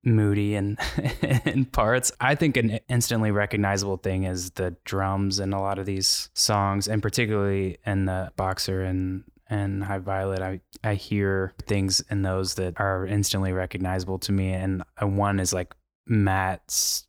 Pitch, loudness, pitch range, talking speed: 100 Hz, -25 LUFS, 95-105 Hz, 160 wpm